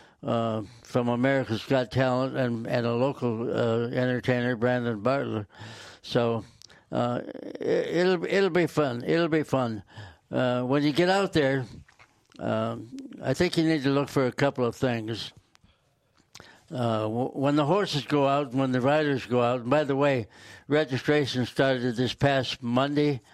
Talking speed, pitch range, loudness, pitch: 160 wpm, 115-145 Hz, -26 LUFS, 125 Hz